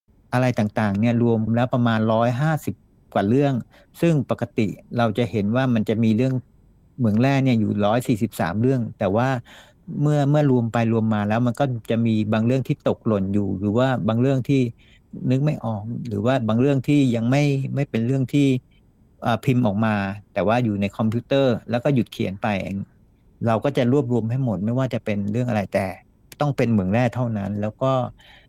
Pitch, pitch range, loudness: 120 Hz, 110-130 Hz, -22 LUFS